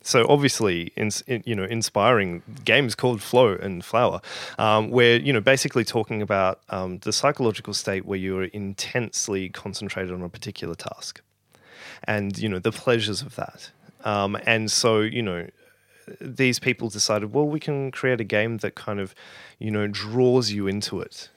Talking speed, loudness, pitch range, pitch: 175 wpm, -23 LUFS, 100-125 Hz, 110 Hz